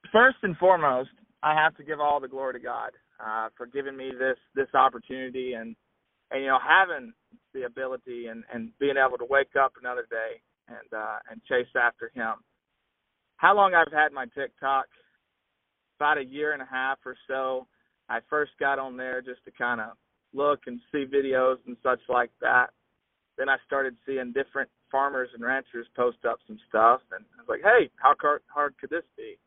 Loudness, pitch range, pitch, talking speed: -26 LUFS, 130-150 Hz, 135 Hz, 190 wpm